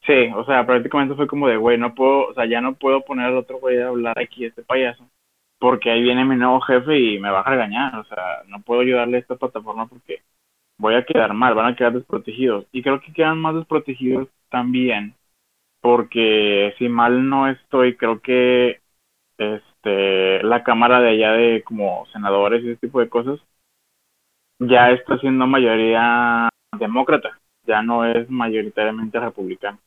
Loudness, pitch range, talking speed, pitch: -18 LUFS, 115-130 Hz, 180 wpm, 120 Hz